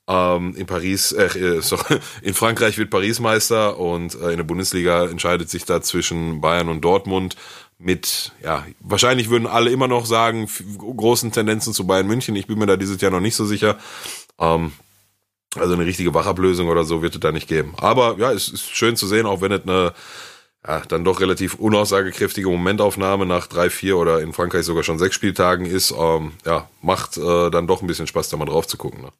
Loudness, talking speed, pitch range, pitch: -19 LUFS, 185 wpm, 85-105 Hz, 95 Hz